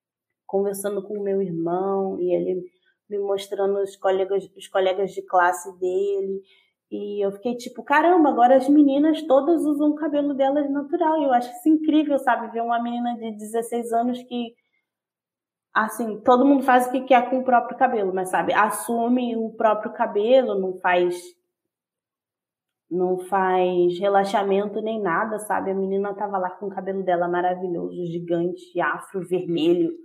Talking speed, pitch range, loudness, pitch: 160 wpm, 190-260 Hz, -22 LUFS, 215 Hz